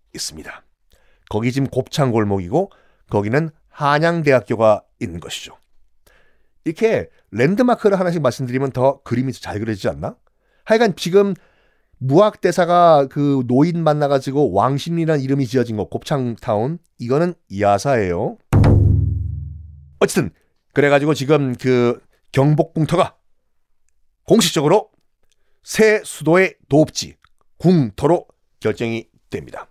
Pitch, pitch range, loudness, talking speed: 140 Hz, 115-165 Hz, -18 LUFS, 270 characters per minute